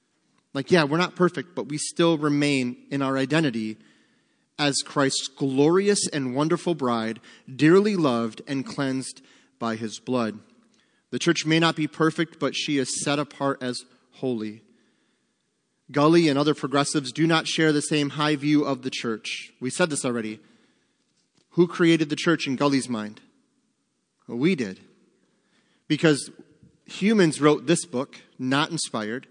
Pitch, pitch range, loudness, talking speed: 145 Hz, 130-160 Hz, -24 LUFS, 150 wpm